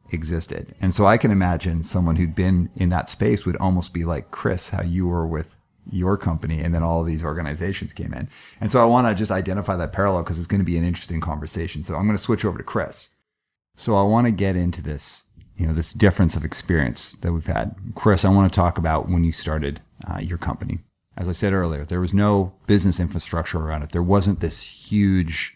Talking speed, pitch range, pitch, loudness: 230 wpm, 85-100 Hz, 90 Hz, -22 LUFS